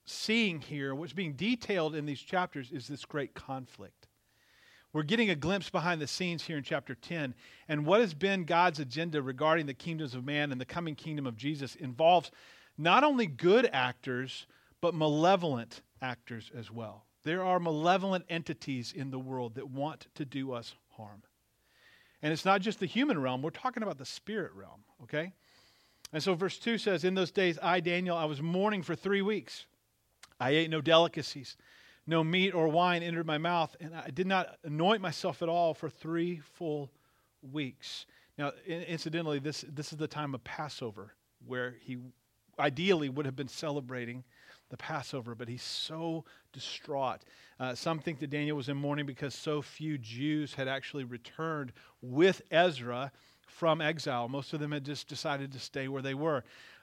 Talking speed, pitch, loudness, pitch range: 175 wpm, 150 Hz, -33 LUFS, 135-170 Hz